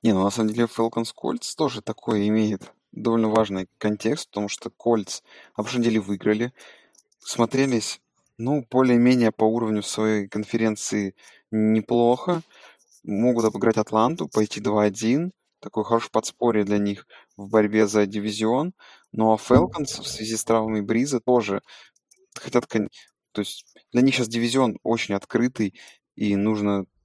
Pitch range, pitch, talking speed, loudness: 105-120 Hz, 110 Hz, 140 wpm, -23 LUFS